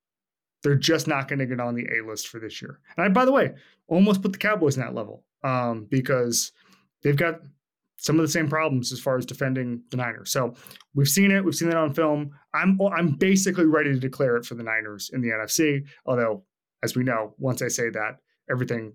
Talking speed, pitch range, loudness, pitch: 225 wpm, 120-160 Hz, -24 LUFS, 140 Hz